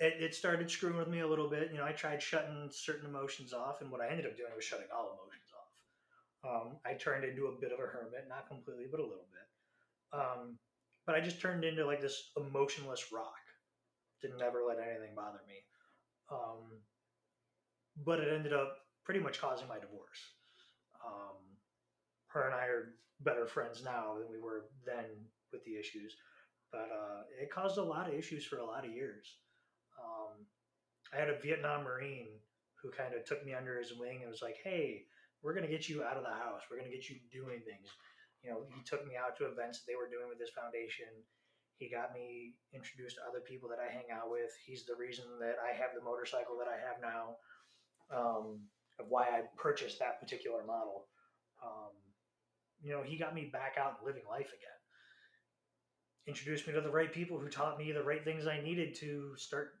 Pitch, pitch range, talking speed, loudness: 130 Hz, 120-155 Hz, 205 wpm, -42 LUFS